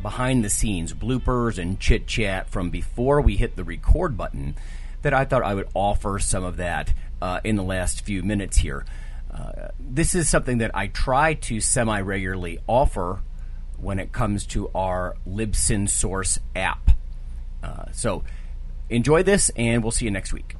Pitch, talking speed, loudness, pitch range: 95 Hz, 170 wpm, -24 LUFS, 75-115 Hz